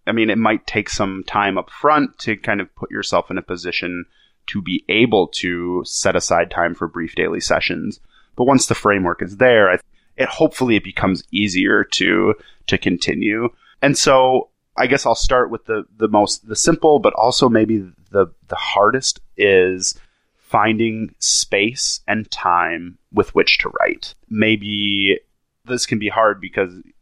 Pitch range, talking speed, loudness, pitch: 95-115 Hz, 165 wpm, -17 LUFS, 105 Hz